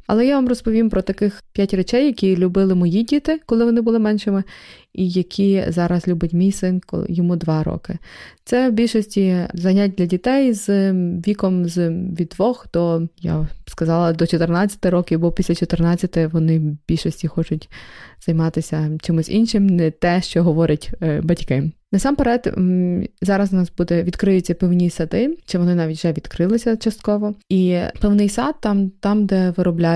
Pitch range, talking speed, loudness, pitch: 170-205 Hz, 160 wpm, -19 LUFS, 185 Hz